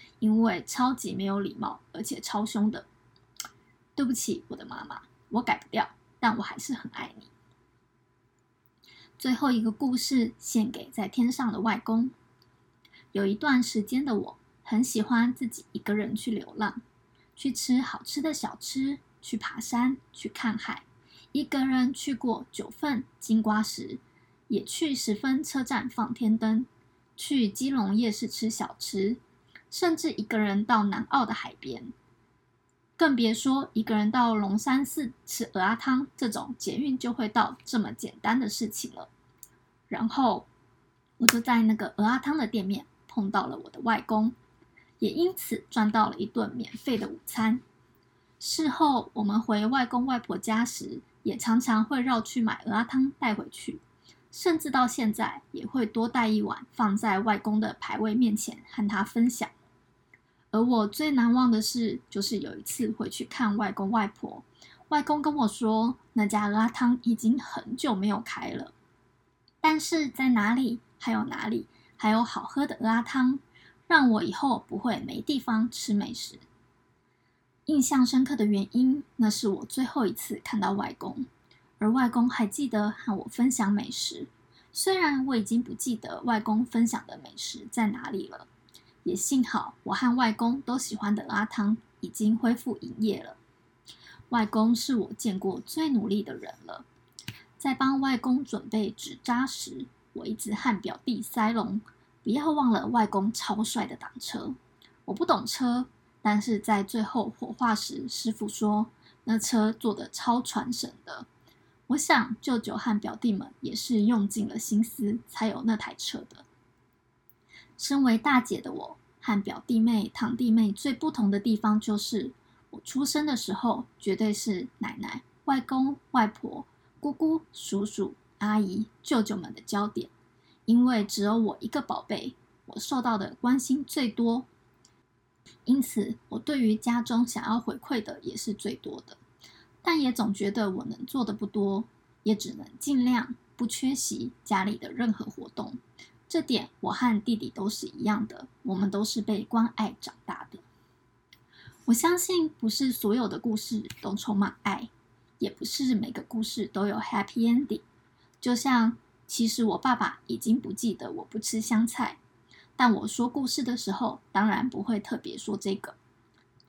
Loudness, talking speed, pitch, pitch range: -28 LUFS, 230 characters per minute, 230 Hz, 215-255 Hz